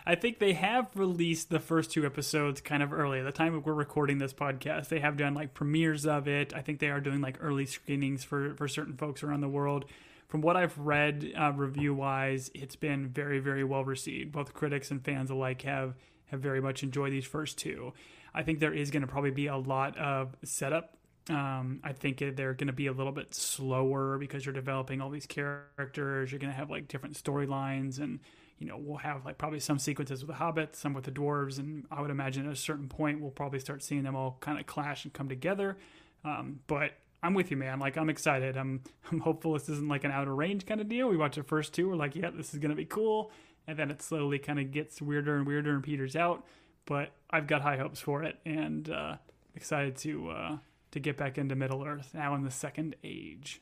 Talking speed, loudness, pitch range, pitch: 235 wpm, -34 LUFS, 140-155 Hz, 145 Hz